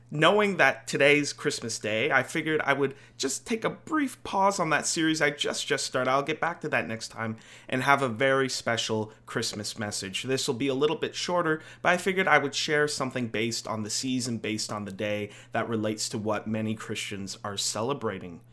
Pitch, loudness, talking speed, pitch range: 130 Hz, -27 LUFS, 210 wpm, 110-145 Hz